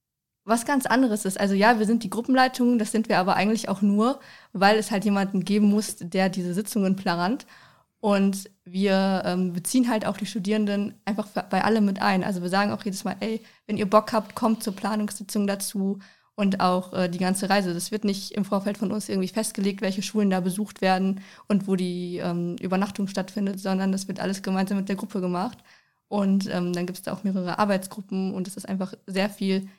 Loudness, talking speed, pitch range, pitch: -25 LUFS, 215 wpm, 190-210 Hz, 200 Hz